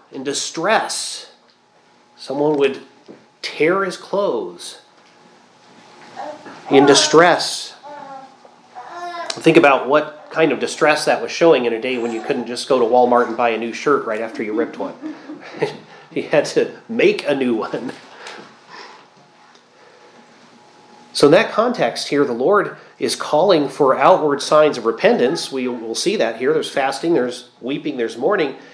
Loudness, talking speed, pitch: -17 LUFS, 145 wpm, 140 Hz